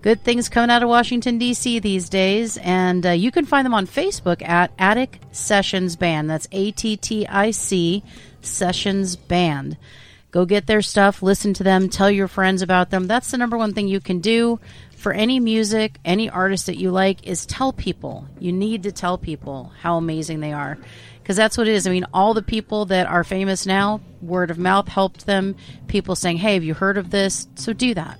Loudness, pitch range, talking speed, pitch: -19 LUFS, 180-215 Hz, 210 wpm, 195 Hz